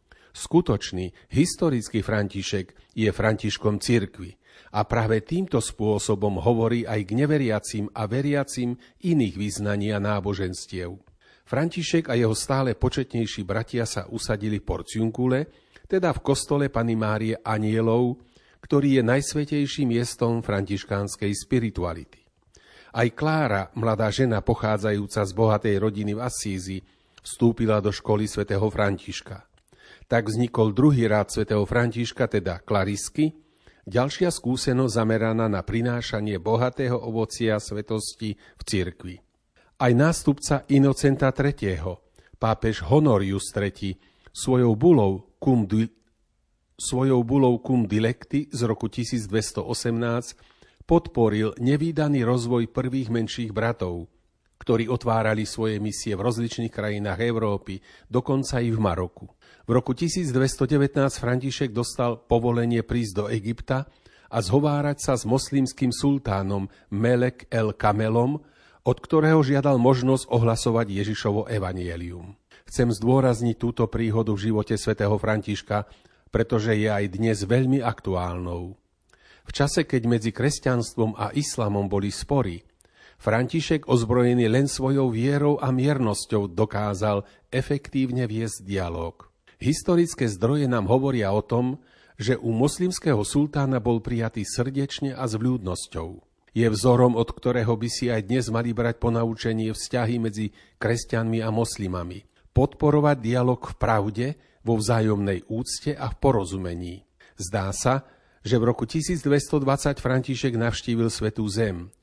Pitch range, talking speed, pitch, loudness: 105-130 Hz, 120 wpm, 115 Hz, -24 LUFS